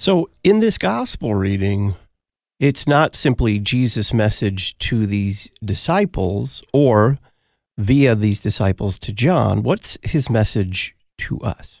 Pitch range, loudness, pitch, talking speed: 100-140 Hz, -18 LUFS, 110 Hz, 120 wpm